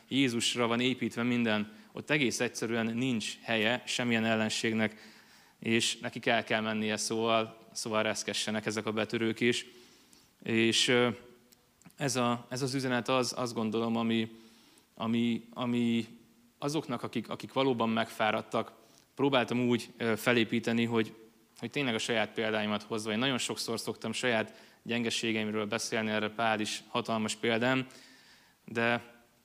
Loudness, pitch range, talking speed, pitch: -31 LUFS, 110-120 Hz, 130 wpm, 115 Hz